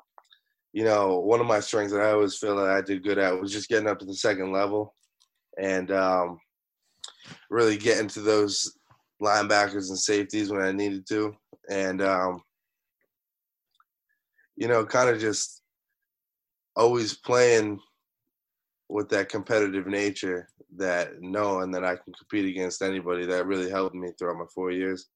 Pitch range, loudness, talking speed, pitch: 95-105 Hz, -26 LUFS, 155 wpm, 100 Hz